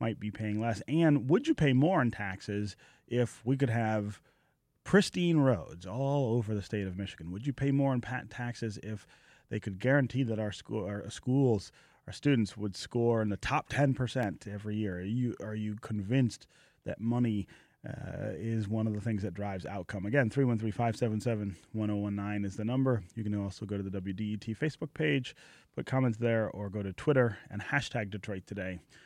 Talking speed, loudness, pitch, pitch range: 185 wpm, -32 LUFS, 110 Hz, 105-130 Hz